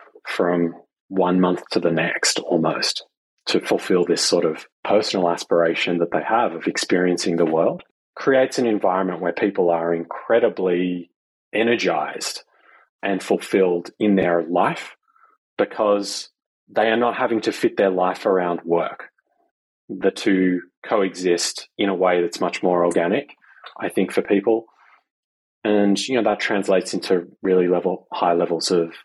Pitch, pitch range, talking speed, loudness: 90 Hz, 85-100 Hz, 145 wpm, -21 LUFS